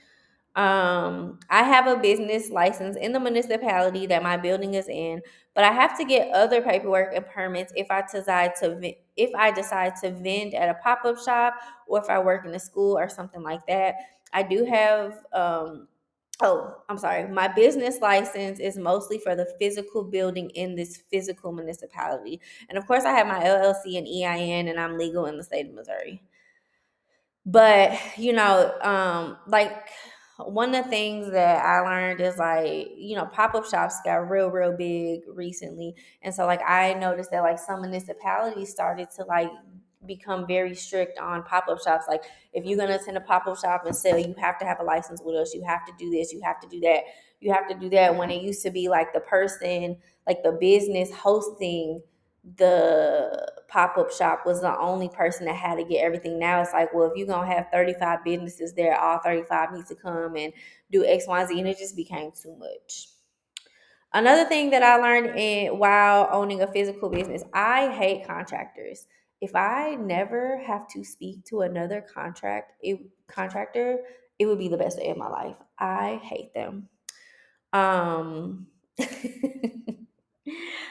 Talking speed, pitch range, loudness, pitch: 185 wpm, 175-210 Hz, -24 LUFS, 190 Hz